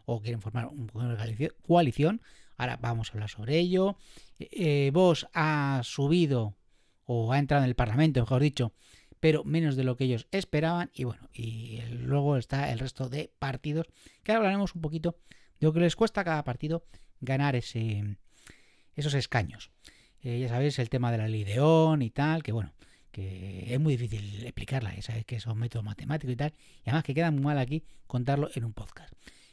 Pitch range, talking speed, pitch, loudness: 115-155 Hz, 185 wpm, 130 Hz, -30 LUFS